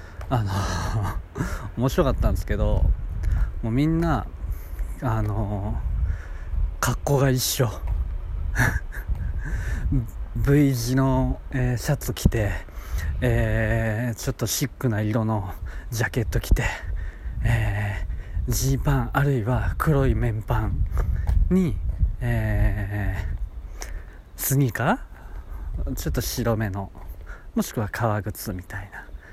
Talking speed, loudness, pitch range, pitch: 190 characters per minute, -25 LUFS, 85-120 Hz, 105 Hz